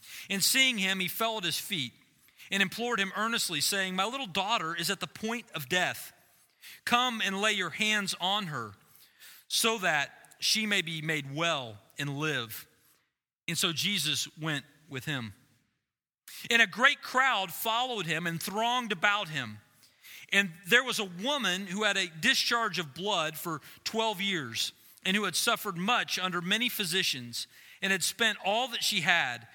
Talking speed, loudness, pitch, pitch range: 170 wpm, -29 LUFS, 195 Hz, 160-220 Hz